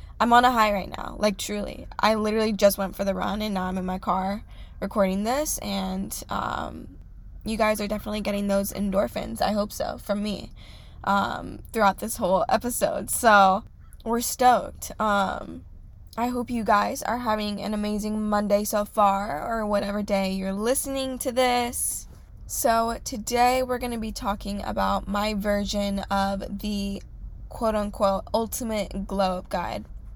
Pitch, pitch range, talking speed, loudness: 205 Hz, 195-220 Hz, 160 wpm, -25 LUFS